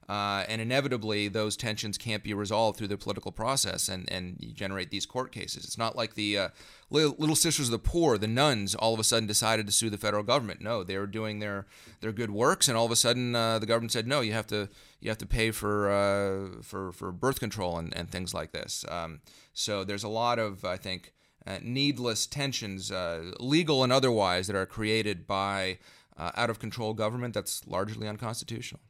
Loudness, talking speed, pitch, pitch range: -29 LUFS, 220 wpm, 110 Hz, 100-115 Hz